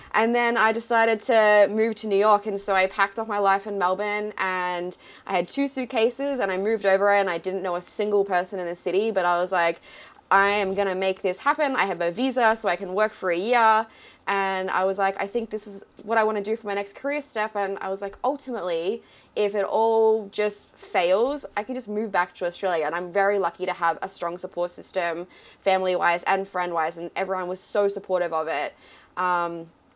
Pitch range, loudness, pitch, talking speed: 180-220 Hz, -24 LUFS, 200 Hz, 235 wpm